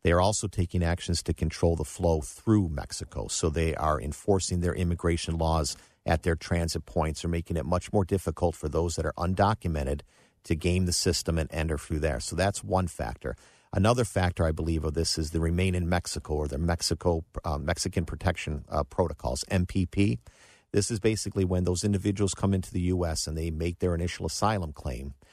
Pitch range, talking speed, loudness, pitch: 80-95 Hz, 195 wpm, -29 LUFS, 85 Hz